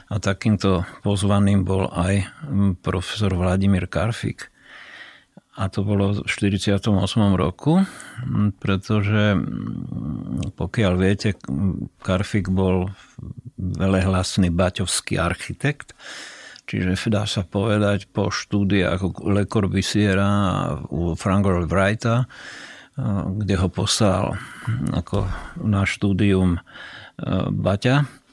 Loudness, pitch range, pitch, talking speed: -22 LUFS, 95-105 Hz, 100 Hz, 85 wpm